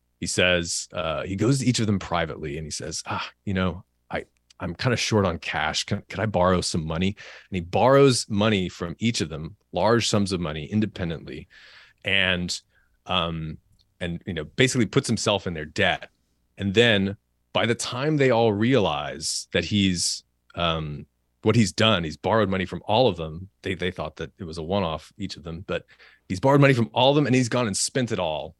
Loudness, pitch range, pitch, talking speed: -24 LUFS, 80-110 Hz, 95 Hz, 210 wpm